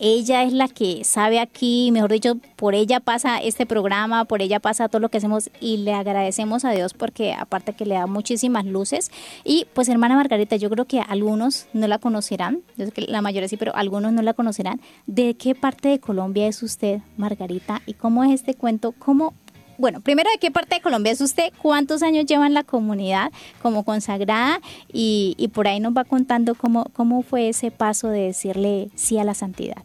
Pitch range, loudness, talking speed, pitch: 210-250 Hz, -21 LUFS, 205 wpm, 225 Hz